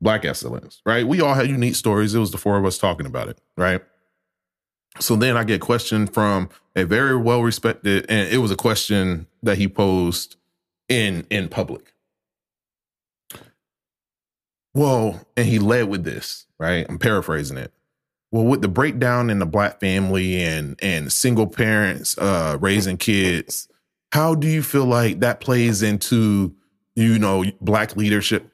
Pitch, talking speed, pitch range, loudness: 105 Hz, 160 wpm, 95-115 Hz, -20 LUFS